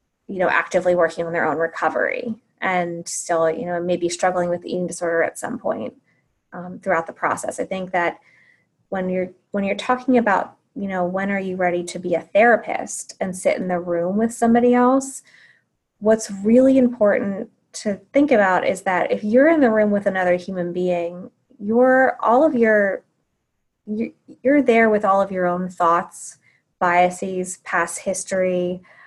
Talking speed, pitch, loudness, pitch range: 175 wpm, 190 Hz, -20 LUFS, 175-225 Hz